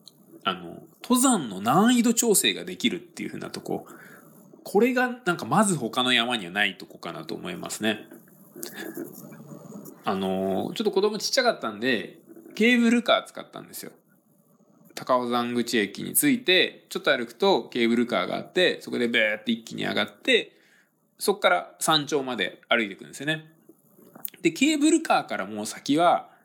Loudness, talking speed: -24 LUFS, 335 characters per minute